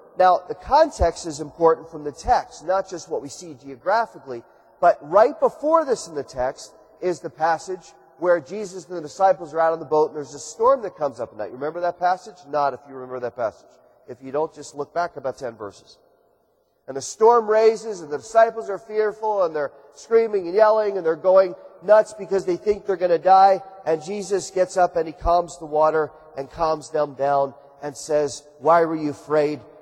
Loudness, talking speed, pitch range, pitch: -21 LUFS, 210 wpm, 145-195 Hz, 165 Hz